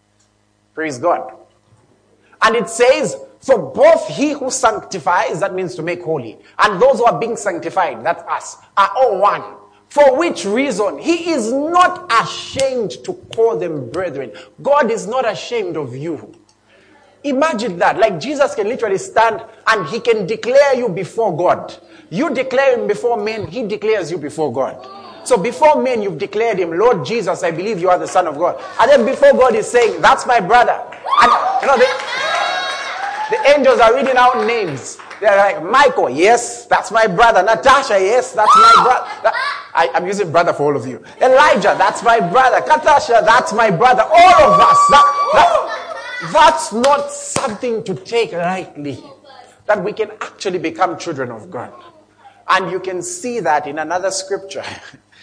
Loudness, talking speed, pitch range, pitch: -14 LUFS, 170 wpm, 195-285 Hz, 235 Hz